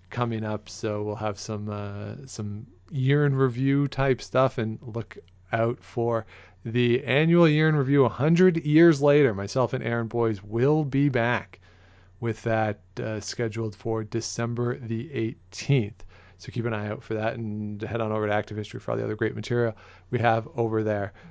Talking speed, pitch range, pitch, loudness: 180 wpm, 105-125 Hz, 115 Hz, -26 LUFS